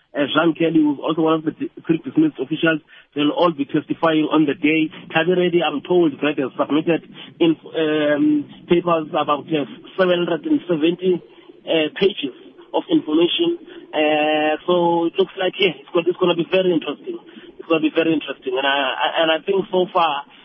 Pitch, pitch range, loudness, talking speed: 165 Hz, 150-185 Hz, -19 LUFS, 180 wpm